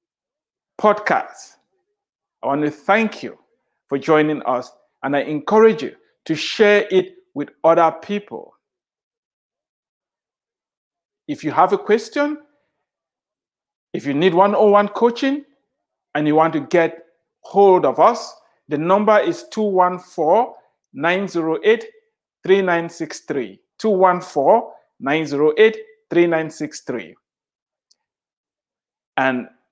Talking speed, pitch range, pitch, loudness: 95 wpm, 160-230 Hz, 190 Hz, -18 LUFS